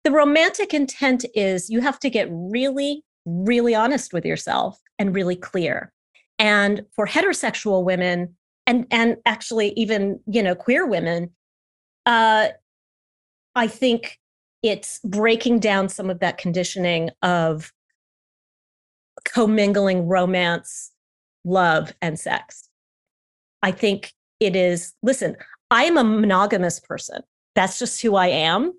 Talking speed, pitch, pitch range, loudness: 125 wpm, 210 Hz, 180-240 Hz, -21 LUFS